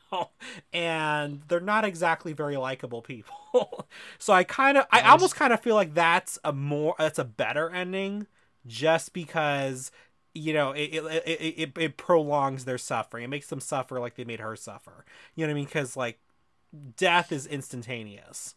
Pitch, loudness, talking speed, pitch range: 155 Hz, -26 LUFS, 175 wpm, 135-175 Hz